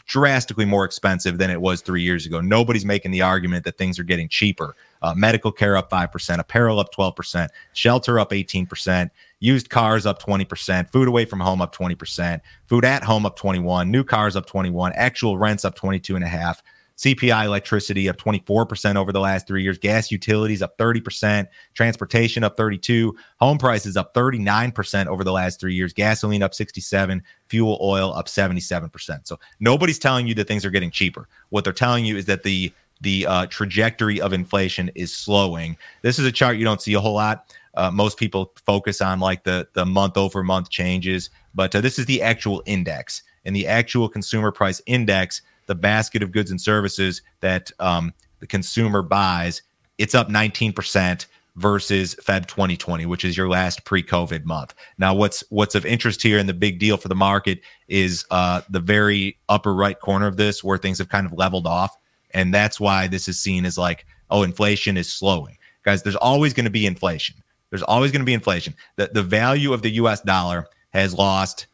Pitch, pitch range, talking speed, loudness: 100 Hz, 95-110 Hz, 190 wpm, -21 LUFS